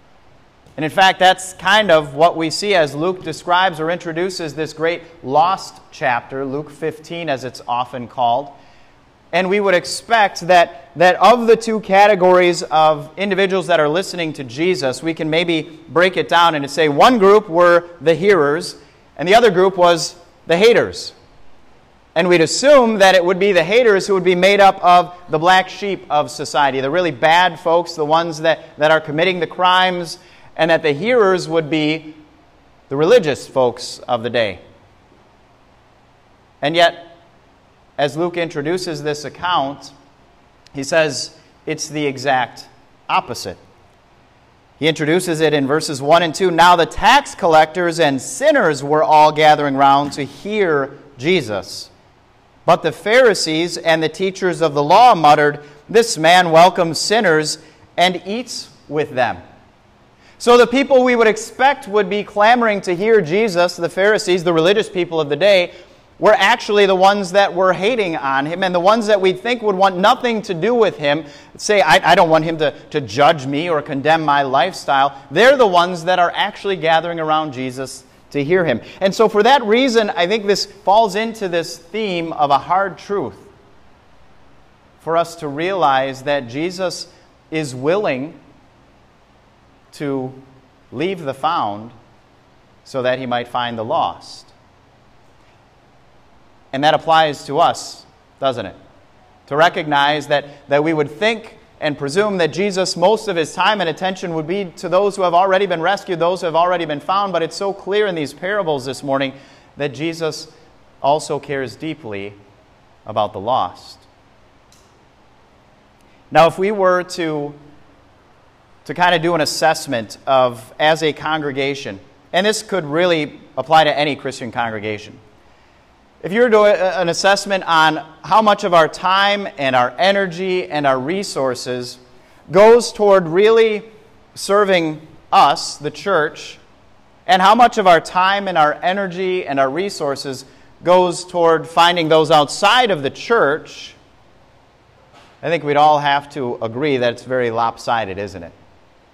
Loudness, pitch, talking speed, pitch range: -15 LUFS, 165 Hz, 160 wpm, 145-190 Hz